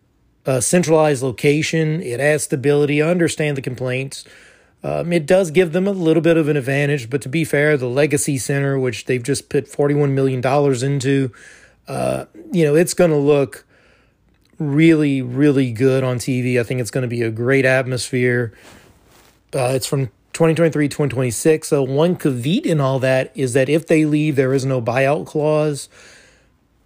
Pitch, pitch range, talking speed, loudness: 145 Hz, 130-155 Hz, 170 wpm, -18 LUFS